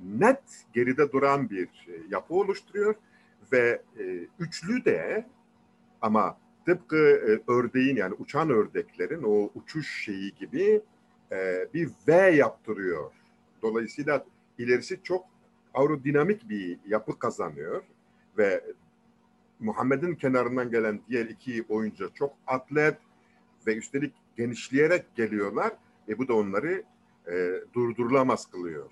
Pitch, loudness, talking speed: 155 Hz, -28 LUFS, 110 wpm